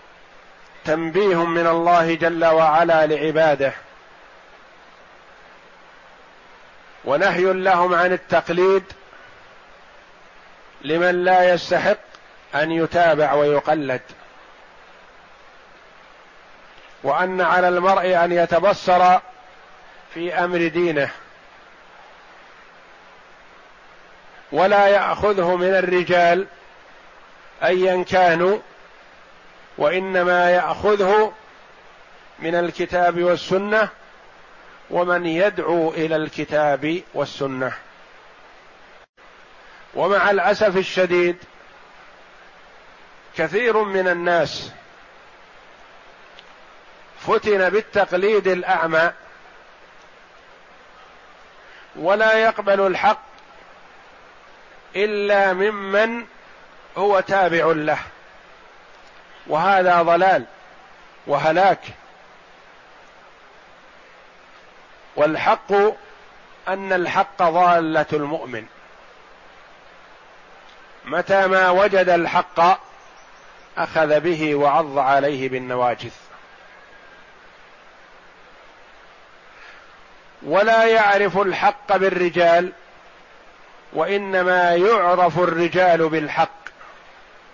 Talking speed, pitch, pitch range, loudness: 55 wpm, 180 Hz, 165-195 Hz, -18 LUFS